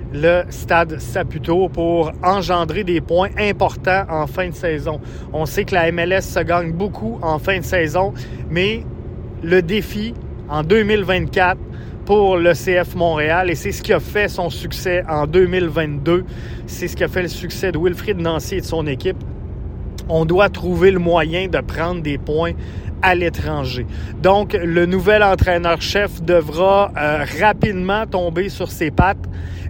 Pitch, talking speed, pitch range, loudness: 170 Hz, 160 wpm, 150-185 Hz, -18 LUFS